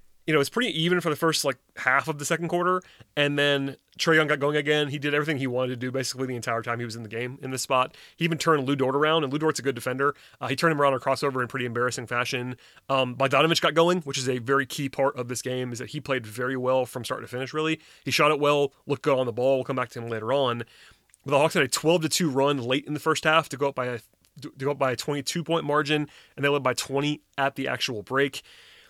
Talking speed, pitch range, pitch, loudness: 290 wpm, 125-150 Hz, 140 Hz, -25 LUFS